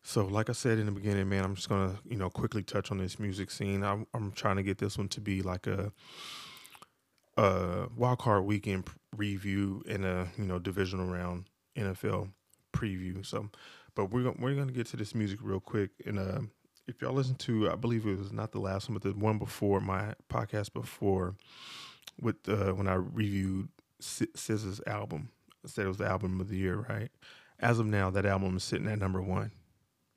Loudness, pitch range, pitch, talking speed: -34 LUFS, 95-110 Hz, 100 Hz, 200 wpm